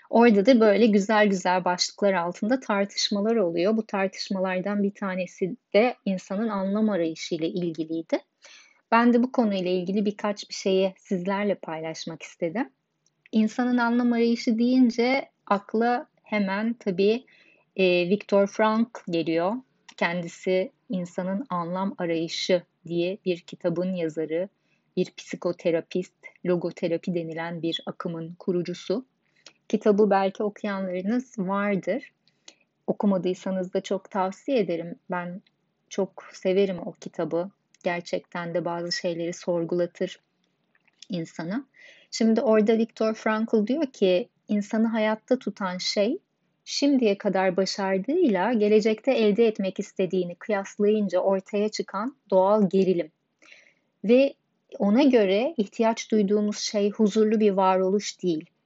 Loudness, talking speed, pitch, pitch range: -25 LUFS, 110 wpm, 195 Hz, 180-220 Hz